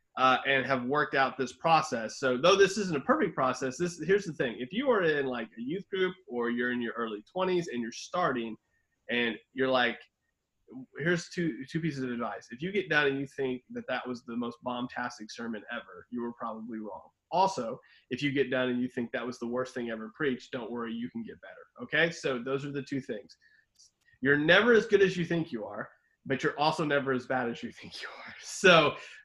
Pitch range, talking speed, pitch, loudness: 120-160 Hz, 230 wpm, 130 Hz, -30 LUFS